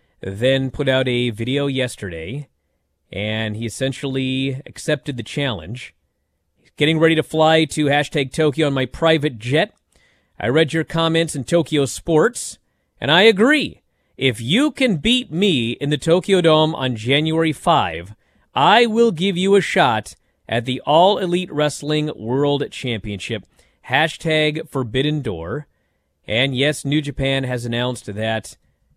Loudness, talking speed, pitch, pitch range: -18 LUFS, 145 wpm, 135 Hz, 115-155 Hz